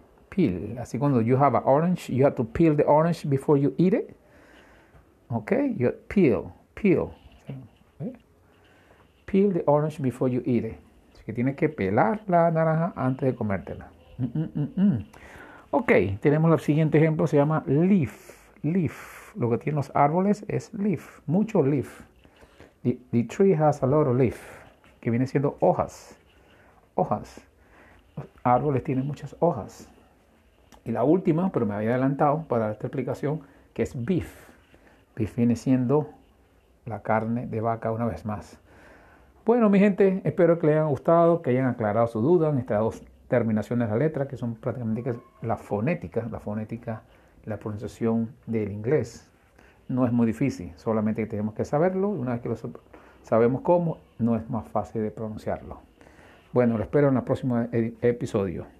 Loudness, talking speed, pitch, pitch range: -25 LUFS, 170 wpm, 125 Hz, 110-150 Hz